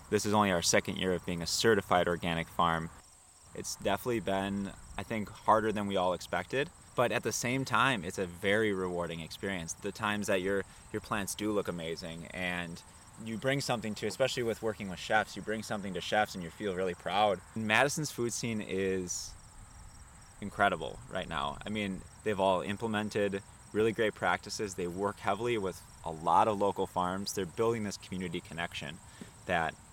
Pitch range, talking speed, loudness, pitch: 90-110 Hz, 180 wpm, -33 LUFS, 100 Hz